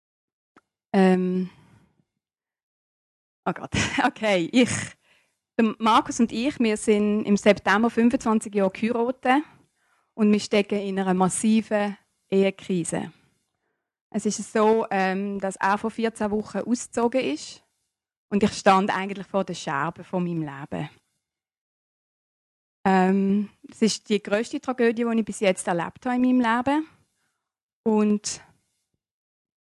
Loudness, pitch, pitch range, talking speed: -24 LUFS, 210 Hz, 190-230 Hz, 120 wpm